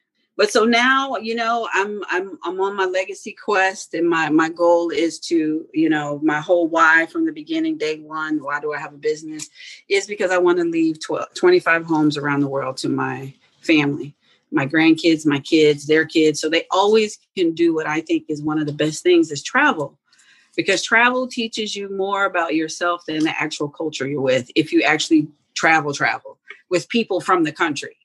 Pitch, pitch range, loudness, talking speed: 170 Hz, 155-230 Hz, -19 LUFS, 200 wpm